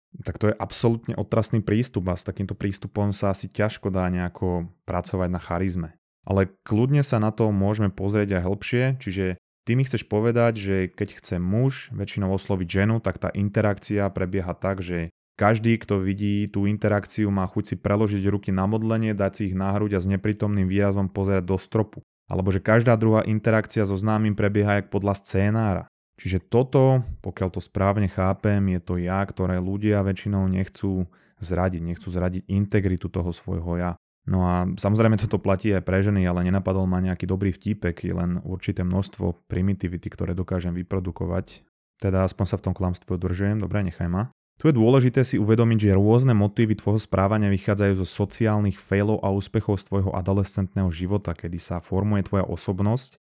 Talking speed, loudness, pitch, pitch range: 175 wpm, -24 LUFS, 100 Hz, 95-105 Hz